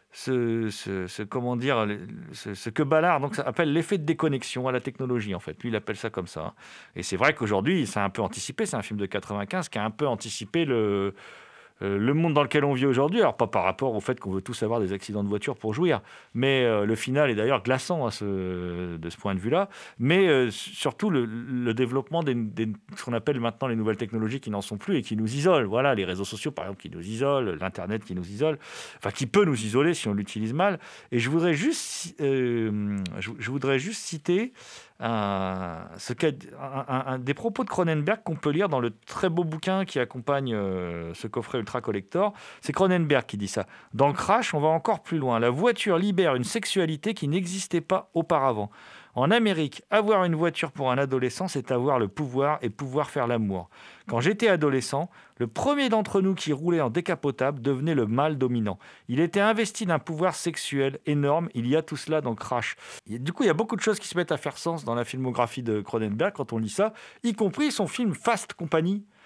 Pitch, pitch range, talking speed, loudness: 135 Hz, 110-170 Hz, 220 wpm, -27 LUFS